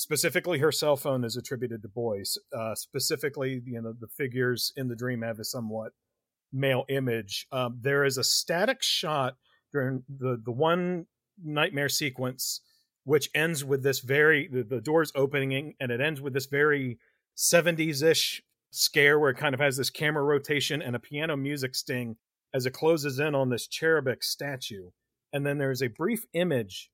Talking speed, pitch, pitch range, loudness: 180 wpm, 135 Hz, 125-150 Hz, -28 LUFS